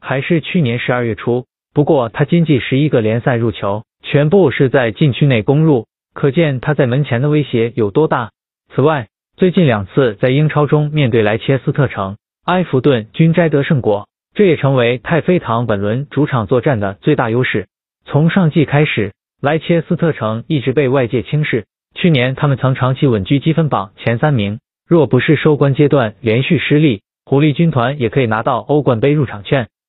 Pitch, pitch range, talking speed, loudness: 140 Hz, 120-155 Hz, 285 characters per minute, -14 LUFS